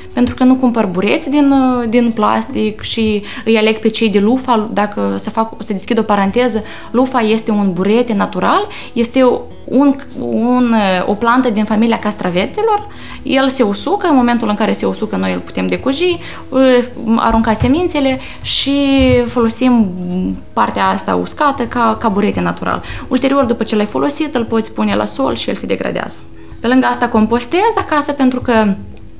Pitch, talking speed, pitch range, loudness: 230 Hz, 165 wpm, 210-260 Hz, -14 LUFS